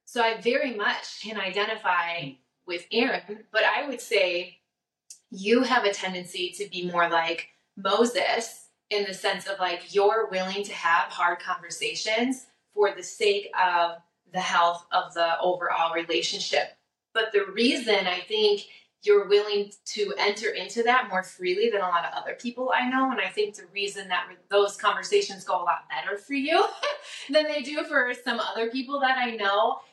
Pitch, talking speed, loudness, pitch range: 205 Hz, 175 wpm, -26 LUFS, 185-260 Hz